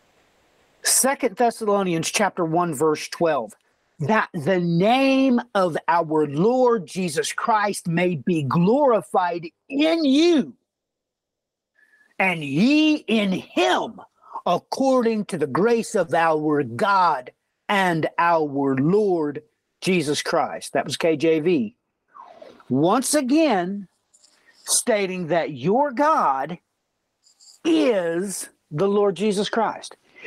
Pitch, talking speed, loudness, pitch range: 195 Hz, 95 wpm, -21 LUFS, 165-245 Hz